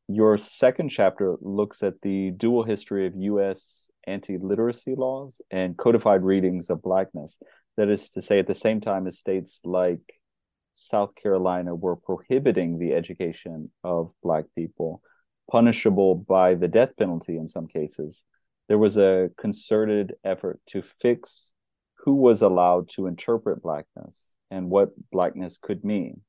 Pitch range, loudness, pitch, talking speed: 90-105 Hz, -24 LUFS, 95 Hz, 145 wpm